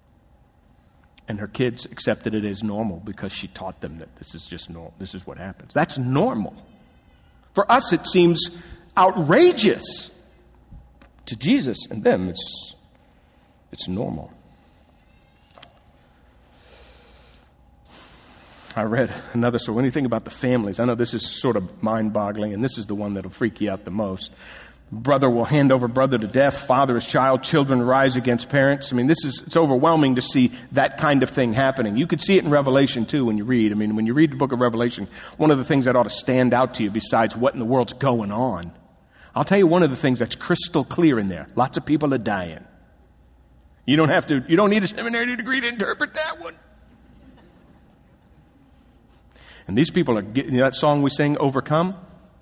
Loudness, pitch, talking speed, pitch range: -21 LUFS, 125 Hz, 190 wpm, 105-150 Hz